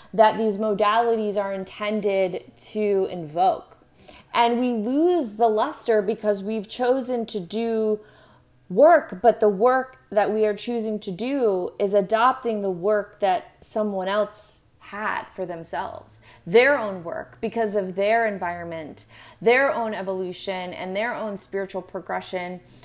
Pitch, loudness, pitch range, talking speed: 210 Hz, -23 LUFS, 195-230 Hz, 135 wpm